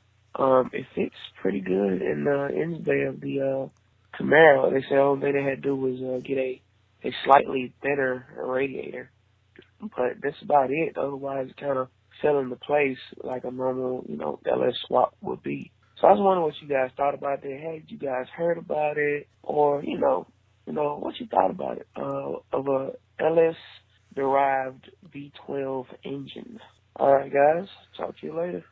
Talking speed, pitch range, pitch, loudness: 190 wpm, 130-145 Hz, 135 Hz, -25 LUFS